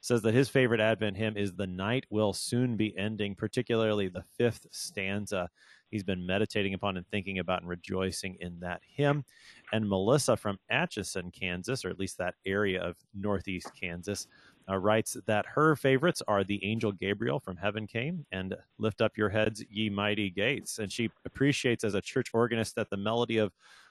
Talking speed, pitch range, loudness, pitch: 185 wpm, 95-115 Hz, -31 LUFS, 105 Hz